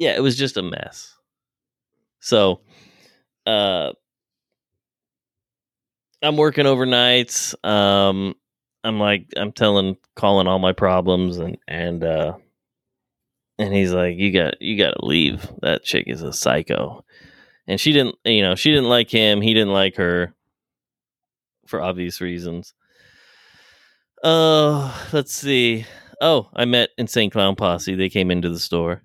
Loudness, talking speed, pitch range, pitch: -19 LUFS, 140 wpm, 95-125 Hz, 105 Hz